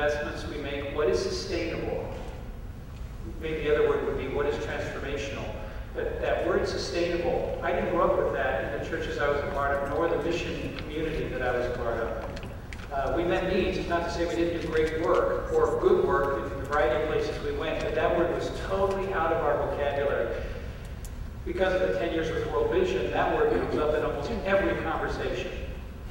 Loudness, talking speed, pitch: -28 LUFS, 205 wpm, 175 Hz